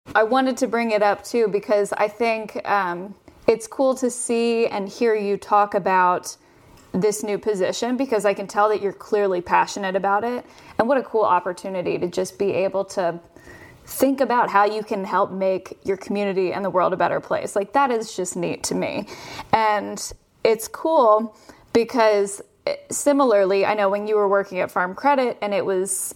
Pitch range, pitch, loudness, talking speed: 195-230 Hz, 205 Hz, -21 LUFS, 190 wpm